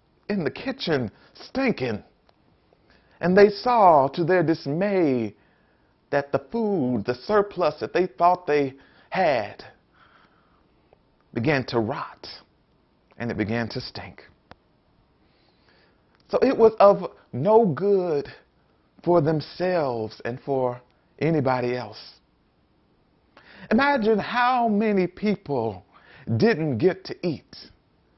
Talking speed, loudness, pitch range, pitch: 100 wpm, -23 LUFS, 130-205 Hz, 170 Hz